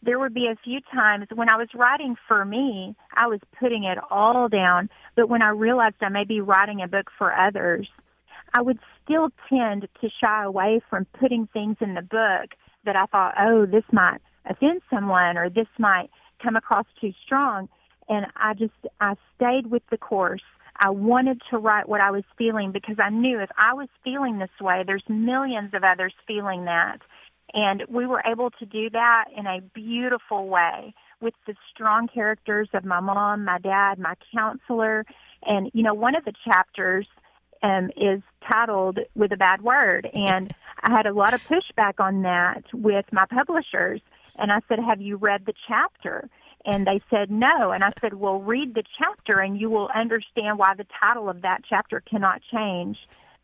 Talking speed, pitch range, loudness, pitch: 190 wpm, 195-235 Hz, -23 LUFS, 215 Hz